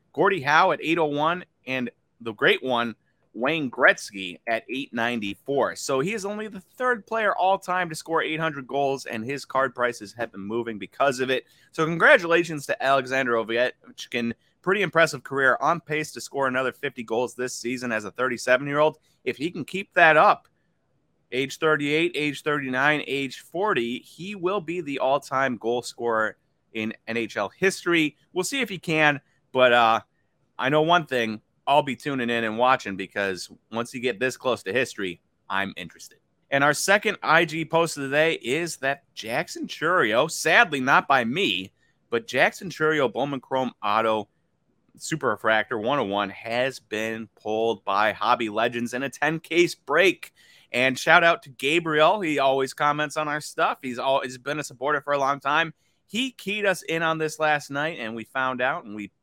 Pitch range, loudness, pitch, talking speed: 120-160 Hz, -24 LUFS, 135 Hz, 175 wpm